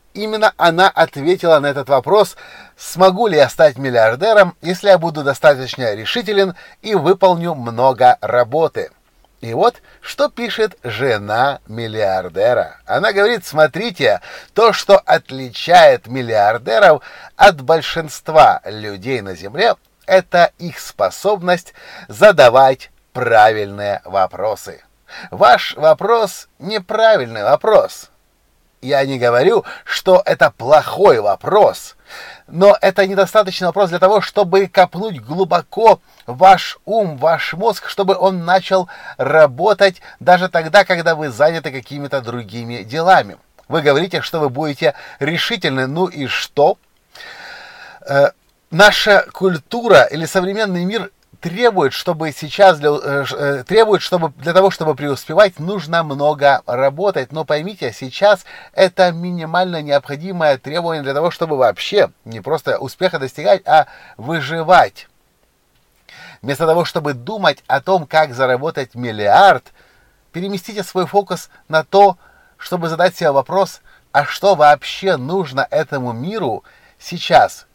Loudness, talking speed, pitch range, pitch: -14 LUFS, 115 wpm, 140-190 Hz, 170 Hz